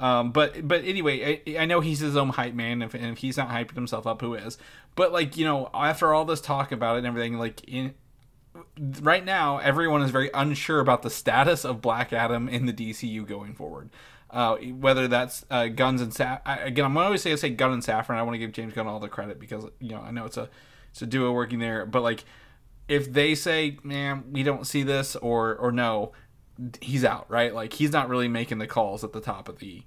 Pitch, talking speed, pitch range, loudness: 125 Hz, 245 wpm, 115-145 Hz, -26 LUFS